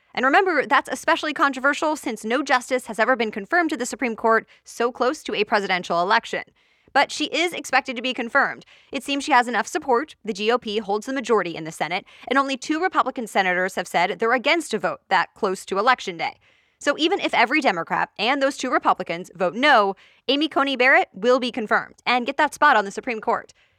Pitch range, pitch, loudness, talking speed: 220-285 Hz, 255 Hz, -21 LUFS, 210 wpm